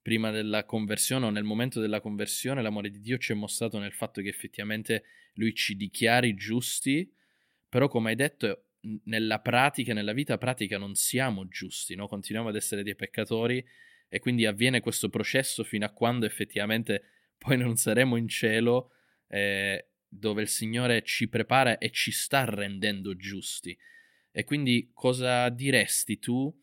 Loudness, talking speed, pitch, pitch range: -28 LUFS, 160 wpm, 115 Hz, 105-125 Hz